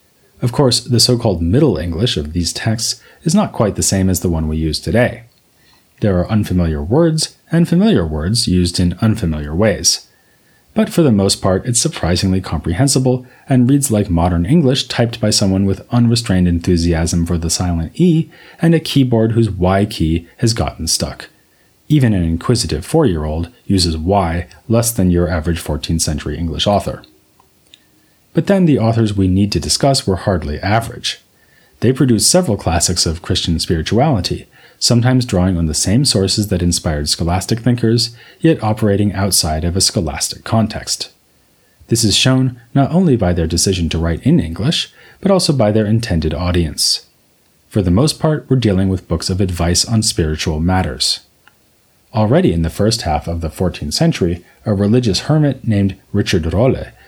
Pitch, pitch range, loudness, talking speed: 100 Hz, 85-120 Hz, -15 LUFS, 170 wpm